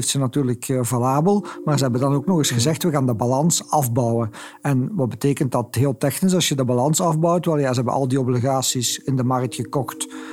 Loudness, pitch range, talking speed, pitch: -20 LUFS, 125-150 Hz, 220 wpm, 135 Hz